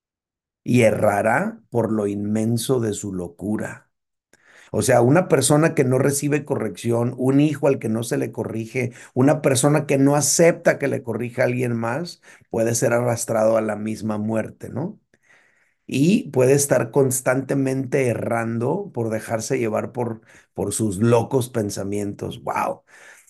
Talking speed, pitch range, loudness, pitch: 145 wpm, 110-135 Hz, -21 LUFS, 120 Hz